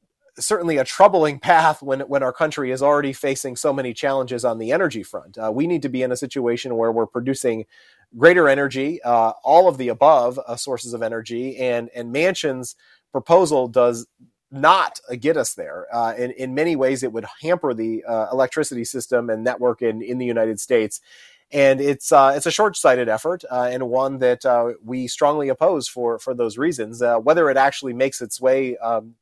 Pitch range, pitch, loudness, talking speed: 120-140 Hz, 125 Hz, -20 LUFS, 200 wpm